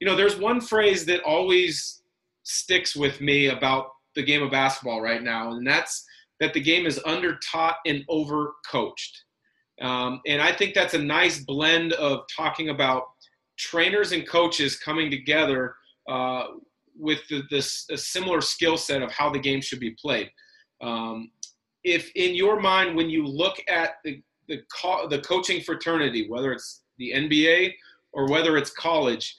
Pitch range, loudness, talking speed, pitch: 135-180 Hz, -24 LUFS, 165 wpm, 155 Hz